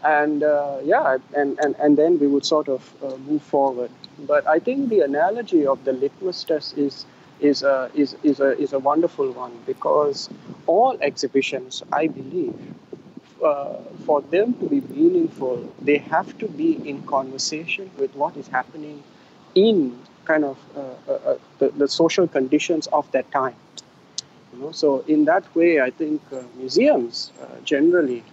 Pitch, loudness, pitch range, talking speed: 150 Hz, -21 LUFS, 135-190 Hz, 165 wpm